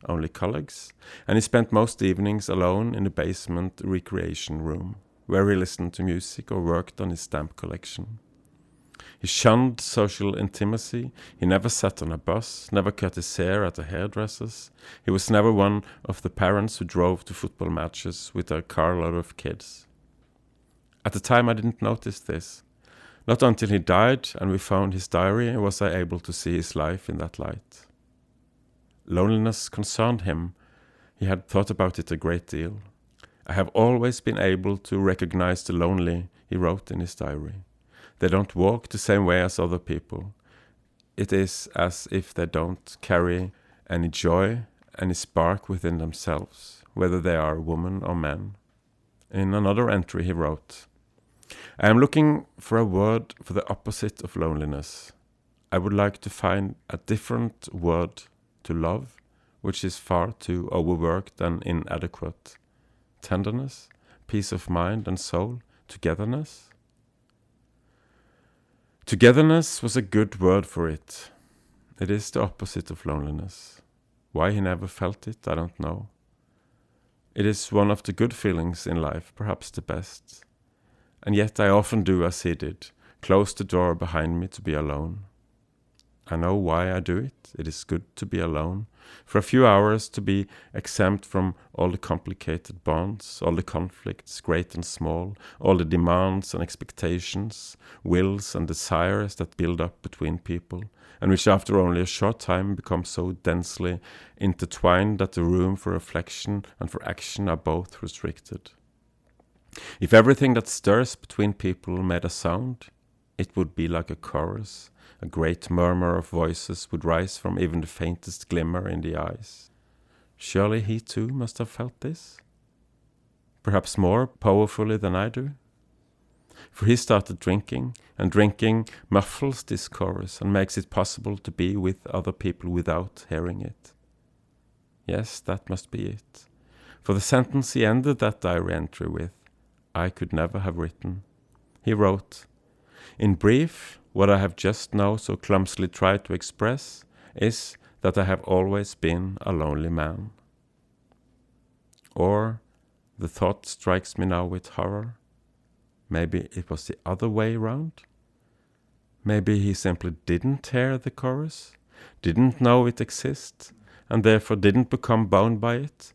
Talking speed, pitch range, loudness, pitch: 155 wpm, 85-110 Hz, -25 LUFS, 95 Hz